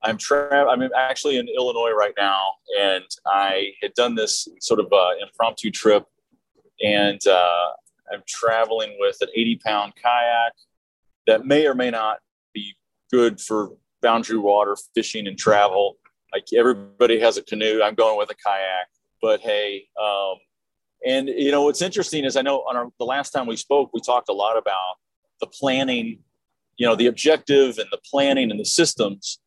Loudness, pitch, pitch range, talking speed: -21 LUFS, 120 Hz, 105-145 Hz, 175 wpm